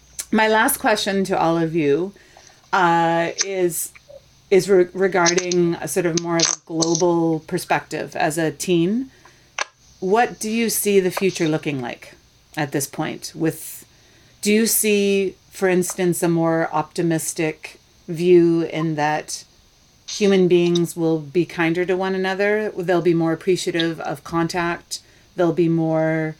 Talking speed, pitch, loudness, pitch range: 145 wpm, 170 Hz, -20 LUFS, 160-190 Hz